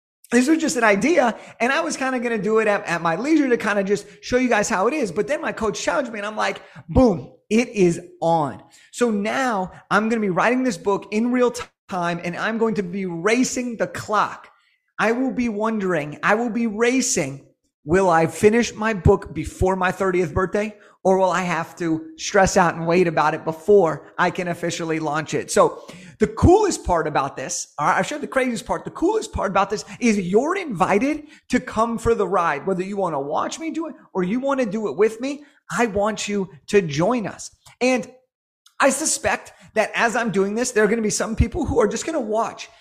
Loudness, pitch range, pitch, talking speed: -21 LUFS, 185-240 Hz, 210 Hz, 225 wpm